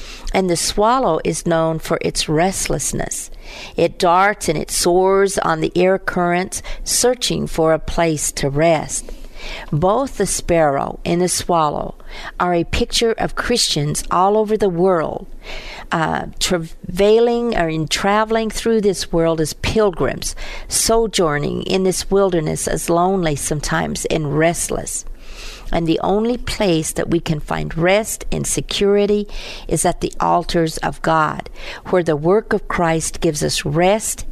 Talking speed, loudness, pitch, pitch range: 145 wpm, -18 LUFS, 180 Hz, 165-205 Hz